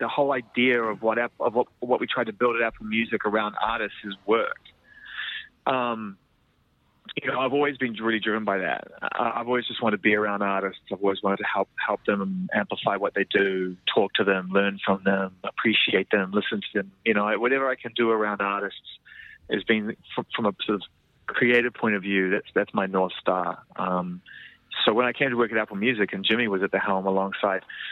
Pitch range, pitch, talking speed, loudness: 95-120 Hz, 110 Hz, 210 wpm, -25 LUFS